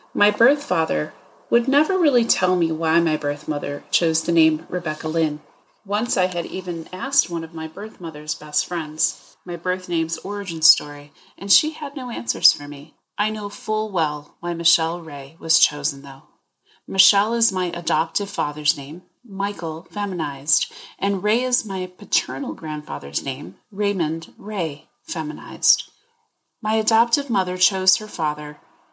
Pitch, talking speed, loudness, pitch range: 175 Hz, 155 wpm, -21 LUFS, 155-205 Hz